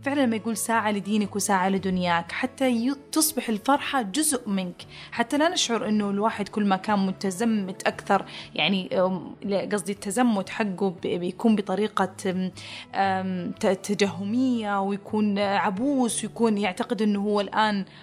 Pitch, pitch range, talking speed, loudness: 205 Hz, 195-235 Hz, 120 wpm, -25 LUFS